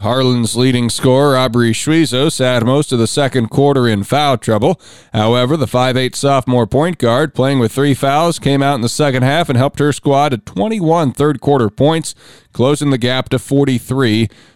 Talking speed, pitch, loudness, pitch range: 180 wpm, 130 Hz, -13 LUFS, 120-145 Hz